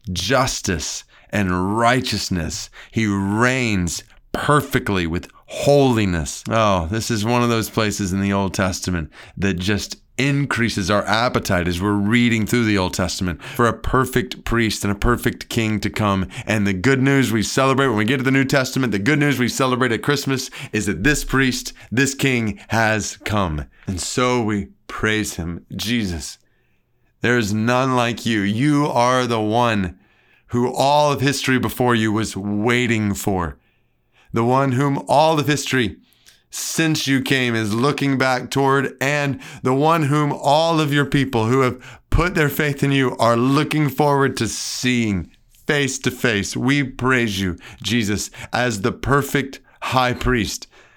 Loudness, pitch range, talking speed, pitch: -19 LUFS, 105-135 Hz, 160 wpm, 120 Hz